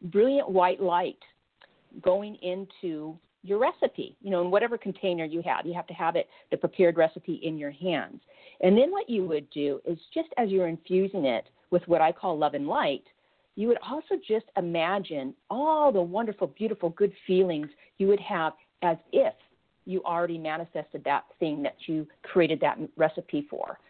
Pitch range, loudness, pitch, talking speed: 165-210 Hz, -28 LUFS, 185 Hz, 180 wpm